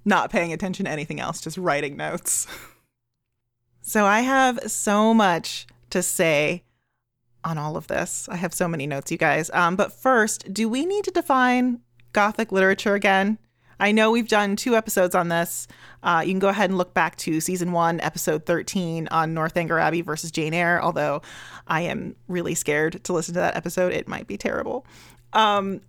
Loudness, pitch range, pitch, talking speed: -23 LUFS, 160-205 Hz, 180 Hz, 185 wpm